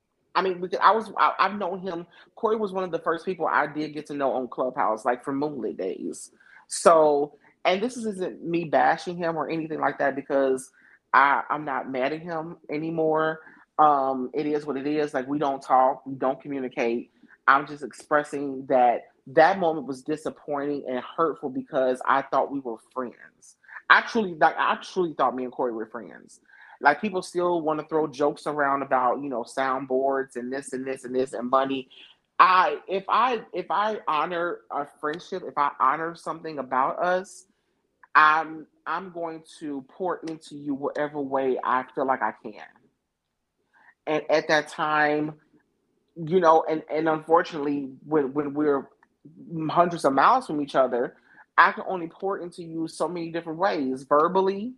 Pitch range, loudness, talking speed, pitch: 135-165 Hz, -25 LUFS, 175 wpm, 150 Hz